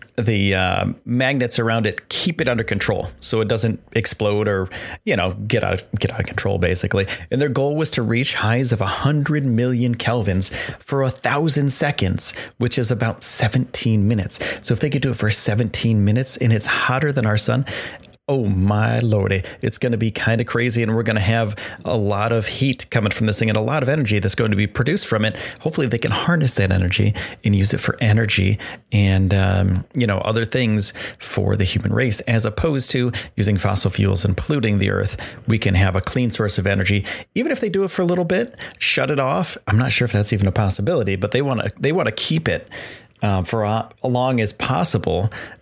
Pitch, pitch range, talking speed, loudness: 110 Hz, 100-125 Hz, 220 wpm, -19 LUFS